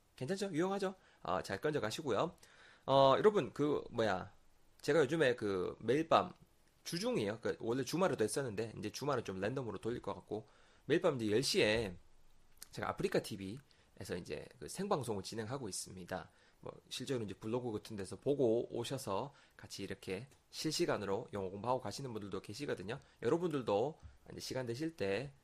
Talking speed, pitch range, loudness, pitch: 355 characters per minute, 100-140 Hz, -38 LUFS, 115 Hz